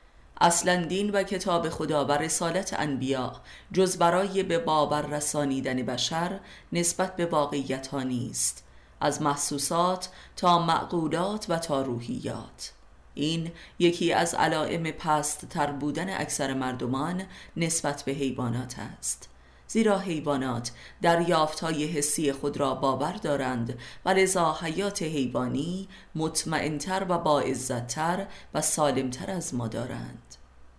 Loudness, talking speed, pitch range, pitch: -27 LUFS, 115 wpm, 130-170 Hz, 150 Hz